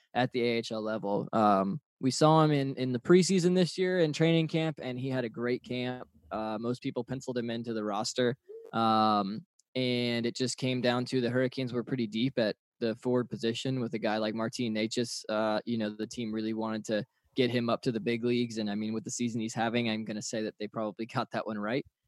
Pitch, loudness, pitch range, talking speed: 120 Hz, -31 LUFS, 110-130 Hz, 235 wpm